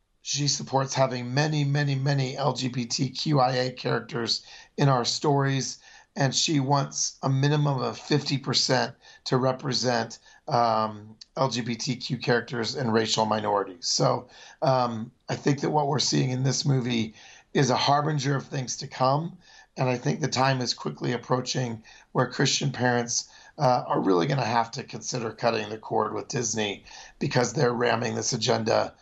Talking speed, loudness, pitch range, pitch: 150 wpm, -26 LUFS, 120-140 Hz, 125 Hz